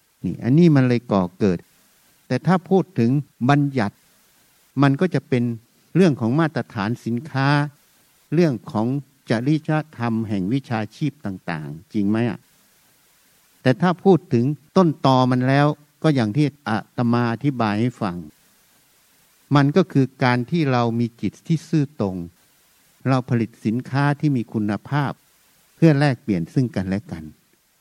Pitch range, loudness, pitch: 115-150 Hz, -21 LUFS, 130 Hz